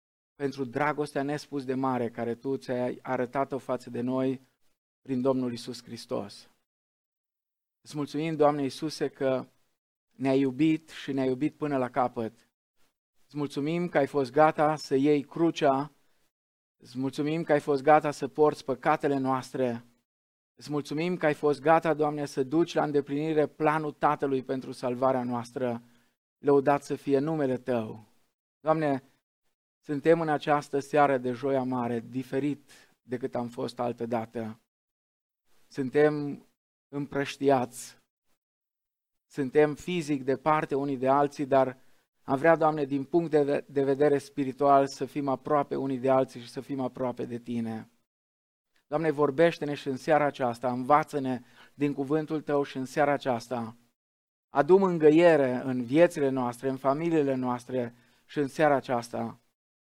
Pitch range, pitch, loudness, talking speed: 125-150 Hz, 140 Hz, -28 LUFS, 140 wpm